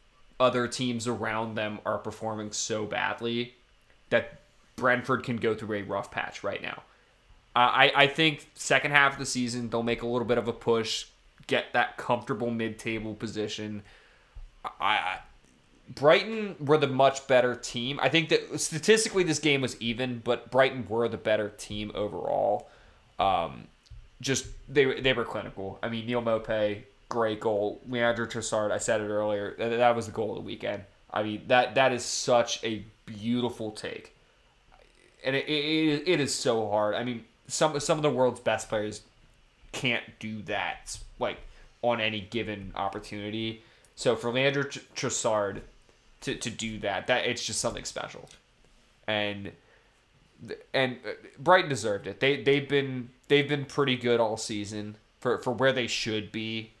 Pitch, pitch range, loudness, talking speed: 120 Hz, 110-130 Hz, -28 LUFS, 165 wpm